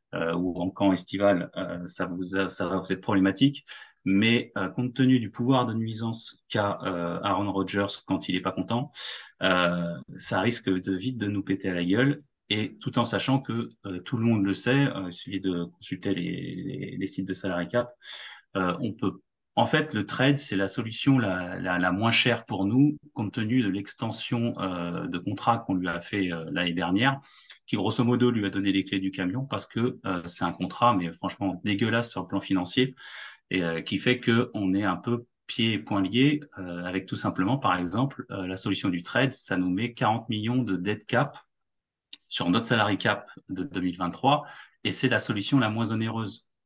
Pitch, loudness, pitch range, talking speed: 100 Hz, -27 LUFS, 95-120 Hz, 210 wpm